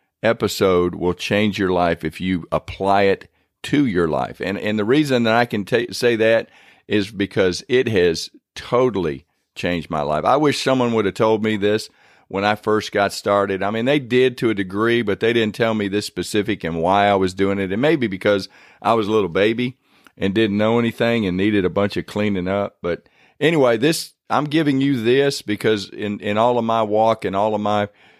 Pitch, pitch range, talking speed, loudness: 105 Hz, 100-115 Hz, 215 wpm, -19 LUFS